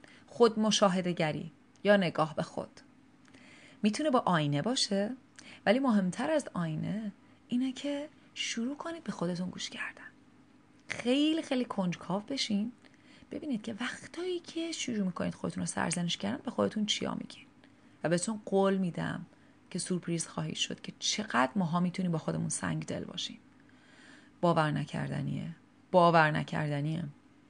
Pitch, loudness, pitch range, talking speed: 230 Hz, -32 LUFS, 180-270 Hz, 135 wpm